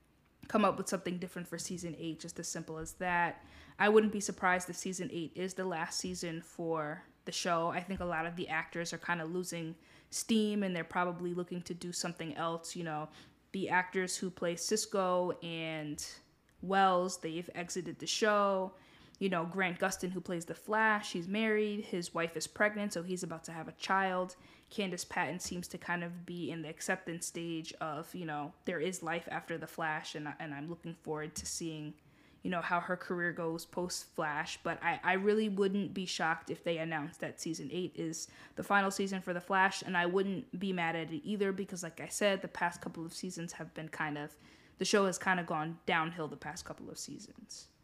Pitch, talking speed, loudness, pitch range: 175 Hz, 210 wpm, -36 LUFS, 165-190 Hz